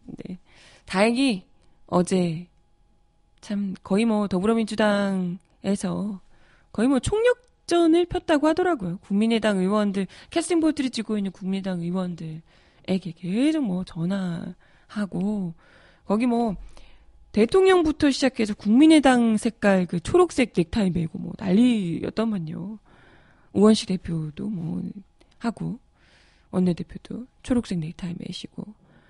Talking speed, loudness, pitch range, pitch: 255 characters per minute, -23 LUFS, 185-235 Hz, 205 Hz